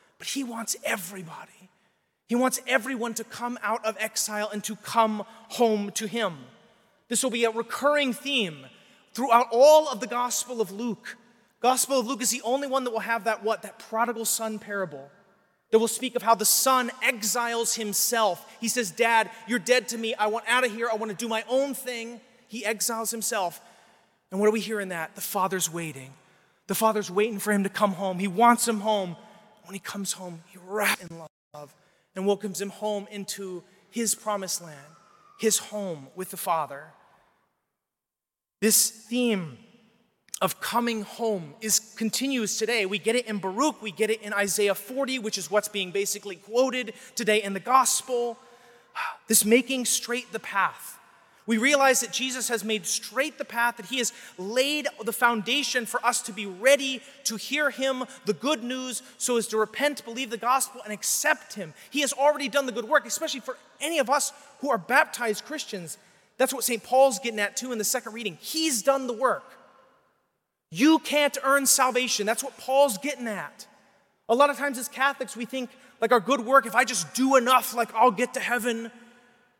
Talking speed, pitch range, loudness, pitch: 190 wpm, 210-255 Hz, -25 LUFS, 230 Hz